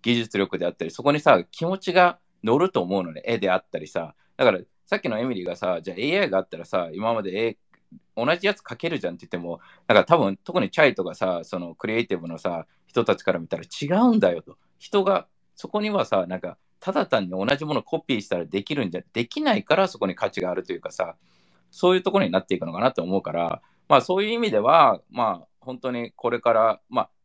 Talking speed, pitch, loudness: 450 characters per minute, 140 Hz, -24 LUFS